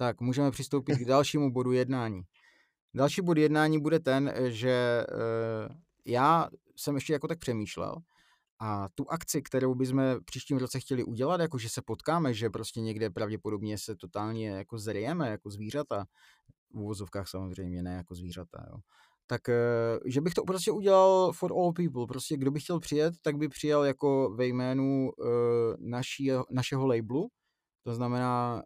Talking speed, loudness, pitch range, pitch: 155 wpm, -30 LUFS, 115-145 Hz, 130 Hz